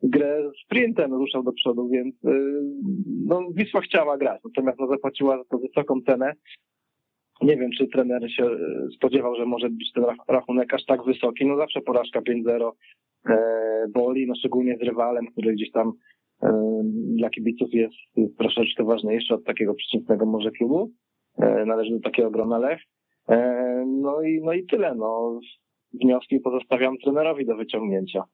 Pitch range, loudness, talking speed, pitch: 115-135 Hz, -24 LUFS, 155 wpm, 125 Hz